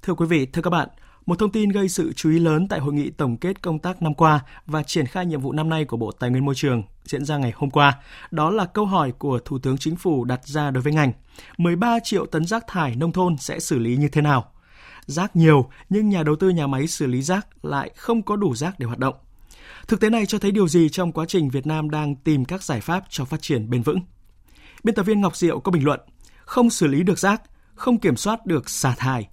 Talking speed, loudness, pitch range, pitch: 260 wpm, -22 LUFS, 140-185 Hz, 155 Hz